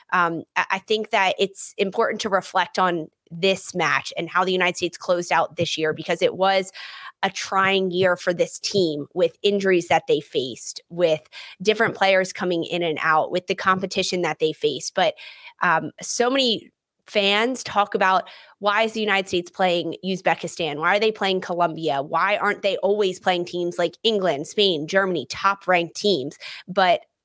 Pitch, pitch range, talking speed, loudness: 185 Hz, 175-200 Hz, 175 wpm, -22 LUFS